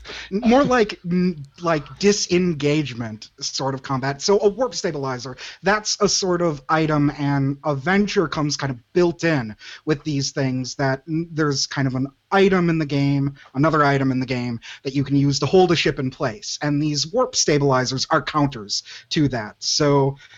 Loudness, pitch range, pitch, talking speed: -21 LUFS, 135-170 Hz, 145 Hz, 175 wpm